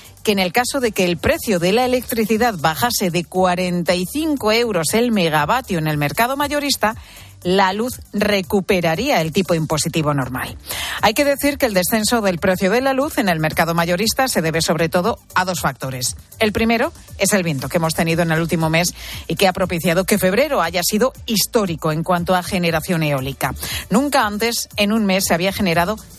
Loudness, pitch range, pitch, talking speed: -18 LUFS, 170-230 Hz, 185 Hz, 190 wpm